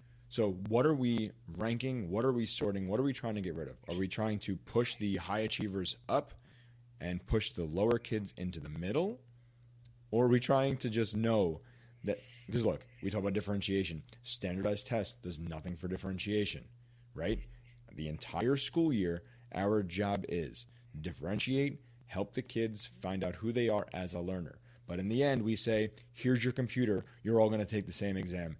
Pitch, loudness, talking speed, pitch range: 110 Hz, -35 LUFS, 190 wpm, 95-120 Hz